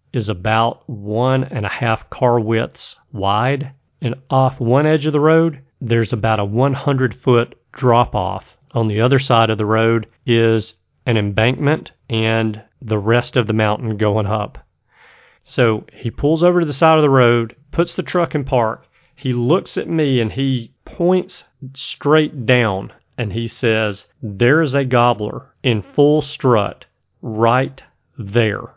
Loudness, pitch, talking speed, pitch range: -17 LUFS, 120 Hz, 160 wpm, 110-135 Hz